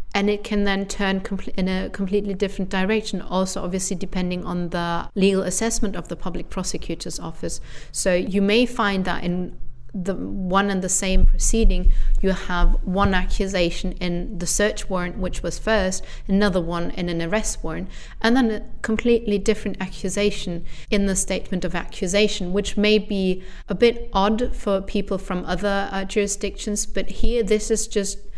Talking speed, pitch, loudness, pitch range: 165 wpm, 195 Hz, -23 LUFS, 185-205 Hz